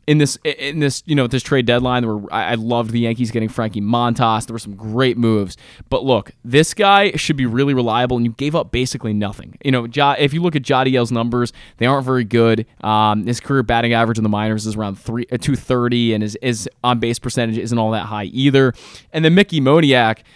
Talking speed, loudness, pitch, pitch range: 225 wpm, -17 LUFS, 120 Hz, 115-135 Hz